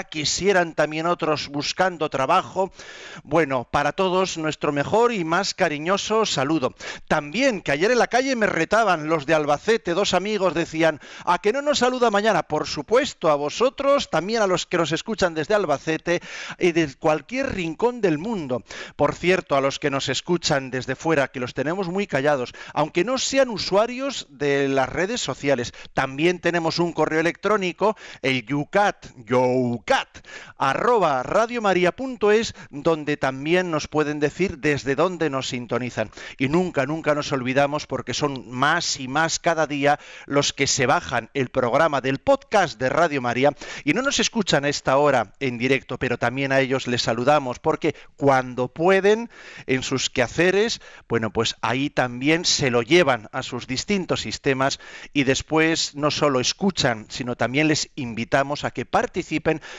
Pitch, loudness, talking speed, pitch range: 155 Hz, -22 LUFS, 165 wpm, 135-180 Hz